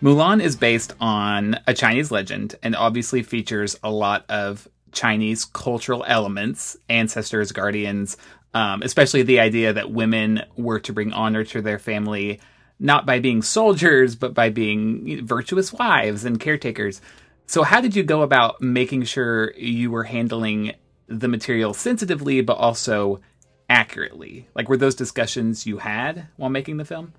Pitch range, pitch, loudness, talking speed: 110-130 Hz, 115 Hz, -20 LUFS, 150 wpm